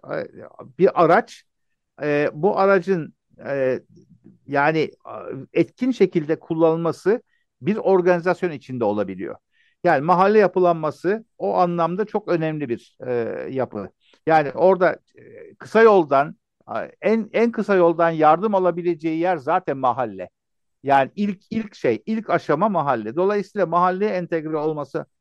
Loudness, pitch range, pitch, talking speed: -21 LUFS, 155-200 Hz, 175 Hz, 105 wpm